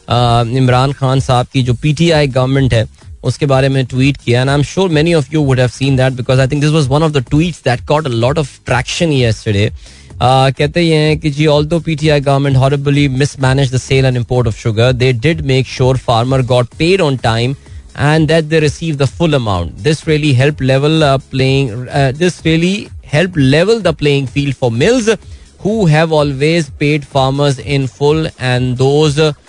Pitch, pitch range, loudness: 140 Hz, 125-155 Hz, -12 LUFS